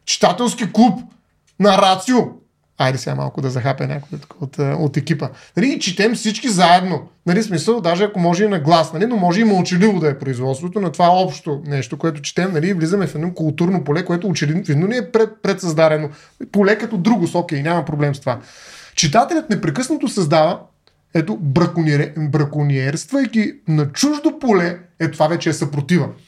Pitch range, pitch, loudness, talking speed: 155-205 Hz, 175 Hz, -17 LUFS, 170 wpm